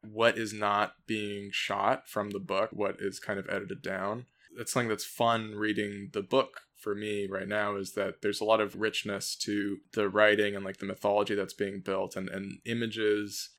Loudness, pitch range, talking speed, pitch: -31 LUFS, 100-105 Hz, 200 wpm, 105 Hz